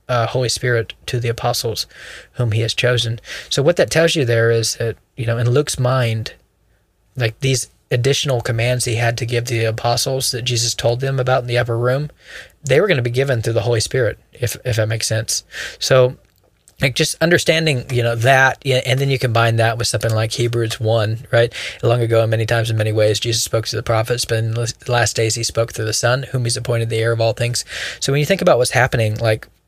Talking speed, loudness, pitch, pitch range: 230 wpm, -17 LUFS, 120 Hz, 115-125 Hz